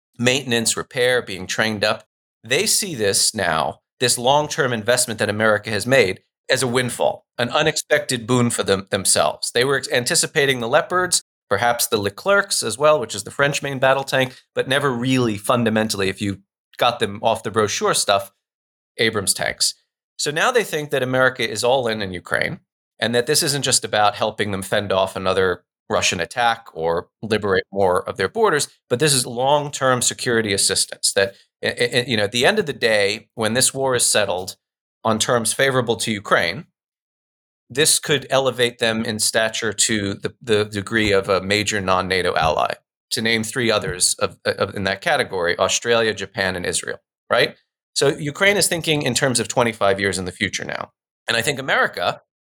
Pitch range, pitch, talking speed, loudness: 105-135 Hz, 120 Hz, 185 wpm, -19 LUFS